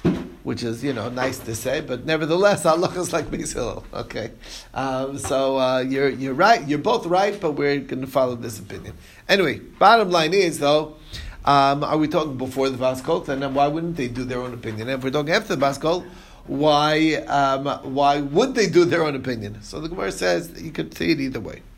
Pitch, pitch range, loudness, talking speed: 140 Hz, 130-160 Hz, -21 LUFS, 220 wpm